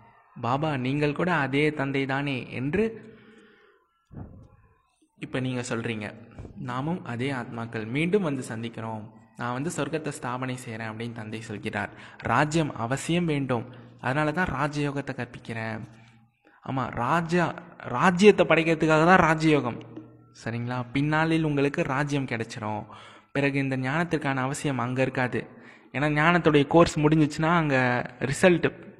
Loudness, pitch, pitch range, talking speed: -26 LUFS, 135 Hz, 120-160 Hz, 110 wpm